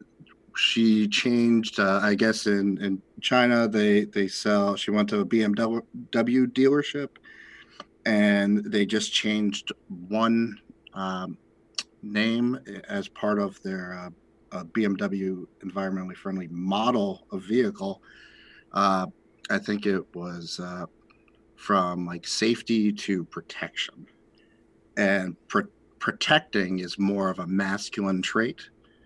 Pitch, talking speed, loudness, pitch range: 105 Hz, 115 wpm, -26 LUFS, 95-110 Hz